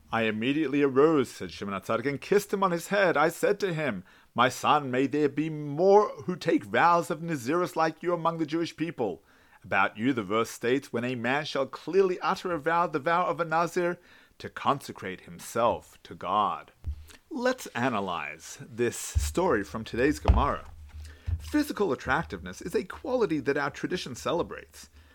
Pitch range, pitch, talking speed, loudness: 120-175 Hz, 155 Hz, 170 wpm, -28 LUFS